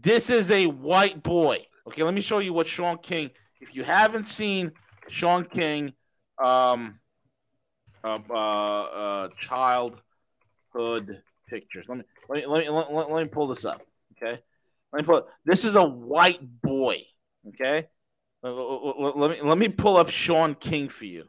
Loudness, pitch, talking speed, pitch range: -24 LUFS, 150 Hz, 170 wpm, 125-170 Hz